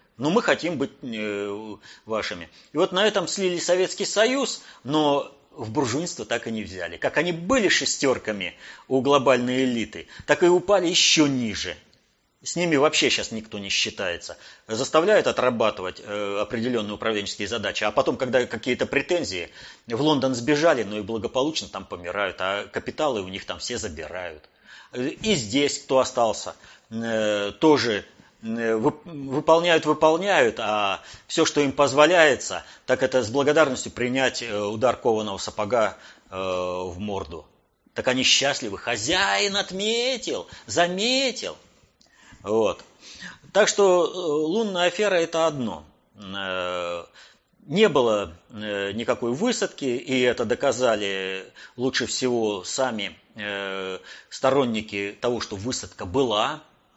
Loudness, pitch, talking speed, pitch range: -23 LUFS, 130 Hz, 120 wpm, 105-155 Hz